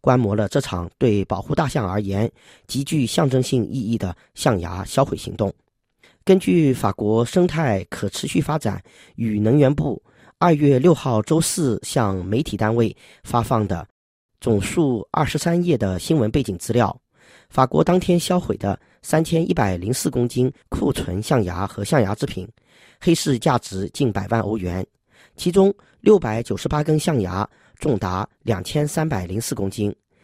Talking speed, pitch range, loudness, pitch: 240 characters per minute, 105-155 Hz, -21 LUFS, 125 Hz